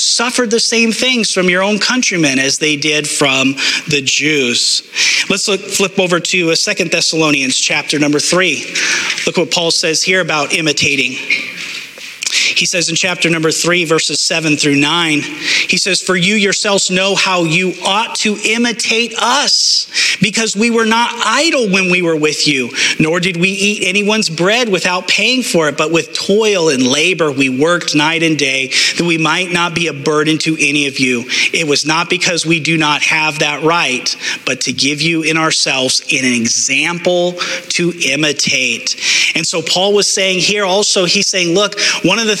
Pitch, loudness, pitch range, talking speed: 170 Hz, -12 LUFS, 150-195 Hz, 180 wpm